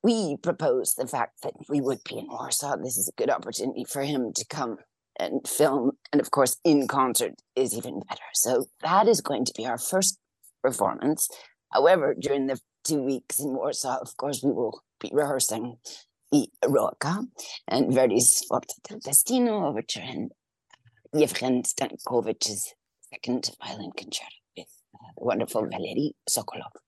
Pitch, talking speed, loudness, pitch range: 140 Hz, 155 wpm, -26 LUFS, 130-190 Hz